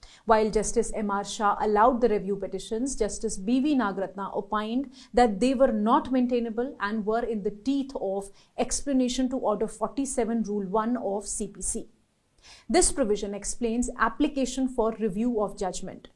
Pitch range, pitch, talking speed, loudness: 205-250 Hz, 225 Hz, 145 wpm, -27 LUFS